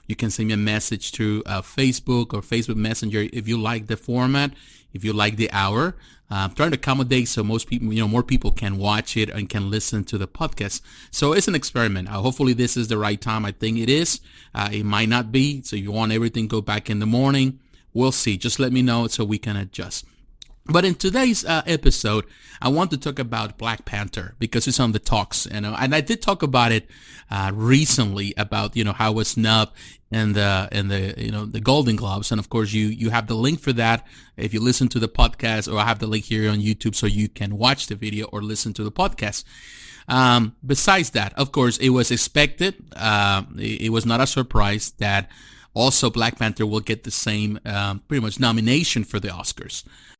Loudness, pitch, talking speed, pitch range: -21 LUFS, 110 Hz, 225 wpm, 105-125 Hz